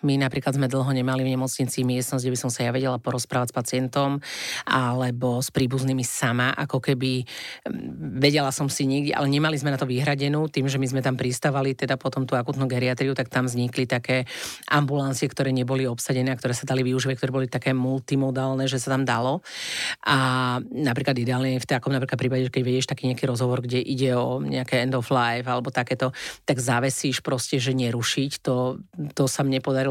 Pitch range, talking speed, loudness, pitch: 125-135 Hz, 195 wpm, -24 LUFS, 130 Hz